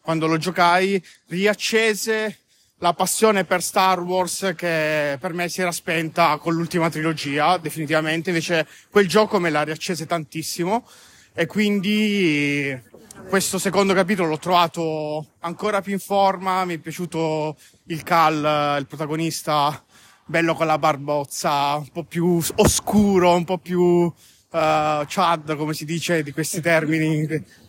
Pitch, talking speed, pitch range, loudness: 170 Hz, 135 wpm, 155-185 Hz, -21 LUFS